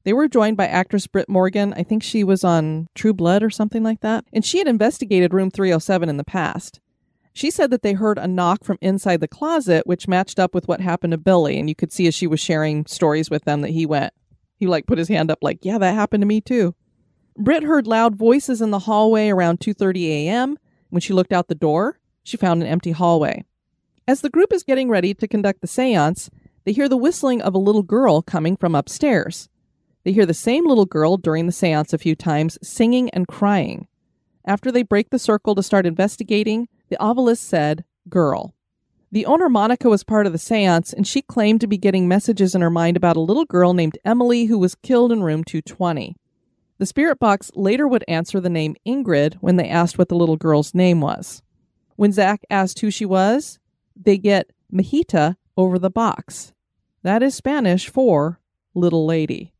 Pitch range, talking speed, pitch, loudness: 170-220 Hz, 210 wpm, 190 Hz, -18 LUFS